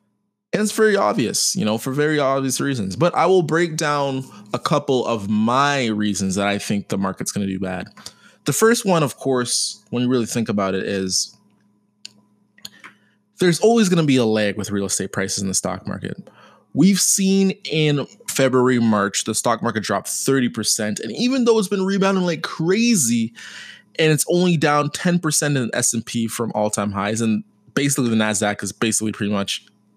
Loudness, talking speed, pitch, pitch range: -19 LUFS, 185 wpm, 120 Hz, 105-160 Hz